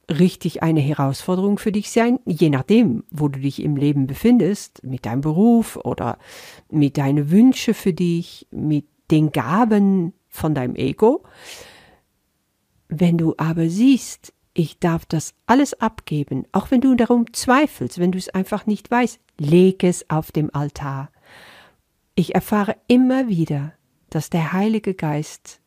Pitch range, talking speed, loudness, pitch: 150-220 Hz, 145 wpm, -19 LUFS, 180 Hz